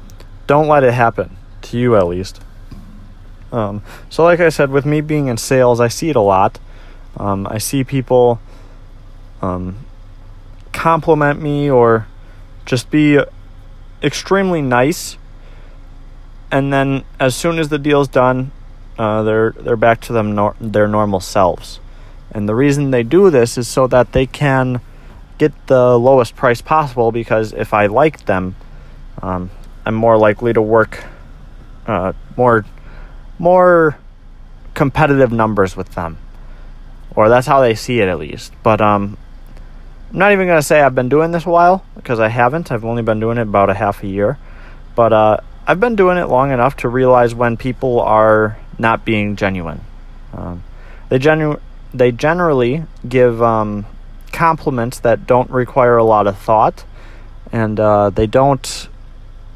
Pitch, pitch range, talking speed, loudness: 120 Hz, 105-135 Hz, 160 wpm, -14 LUFS